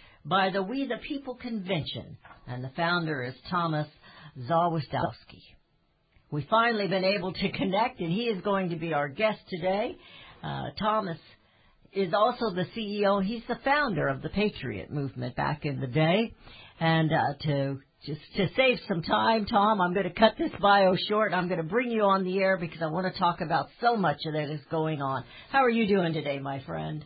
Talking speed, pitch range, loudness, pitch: 195 wpm, 150-210 Hz, -28 LUFS, 180 Hz